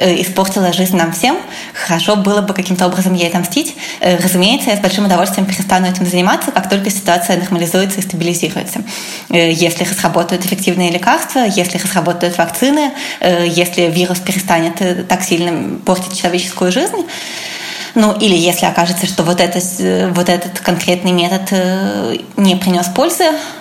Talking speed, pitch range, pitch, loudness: 135 wpm, 175-200 Hz, 185 Hz, -13 LUFS